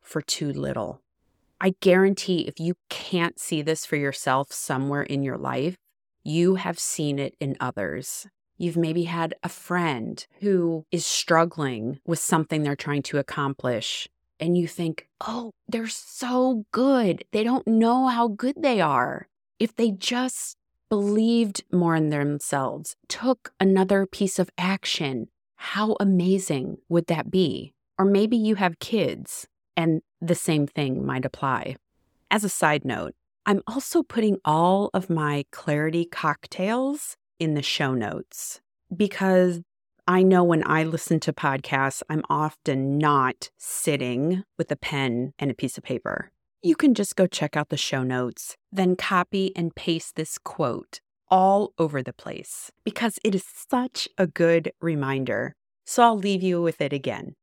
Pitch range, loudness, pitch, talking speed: 150-200 Hz, -24 LUFS, 170 Hz, 155 wpm